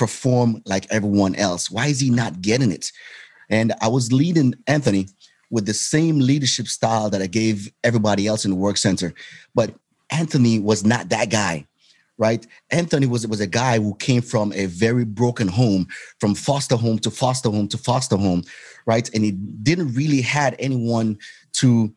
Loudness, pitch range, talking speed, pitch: -20 LUFS, 105-125 Hz, 180 wpm, 115 Hz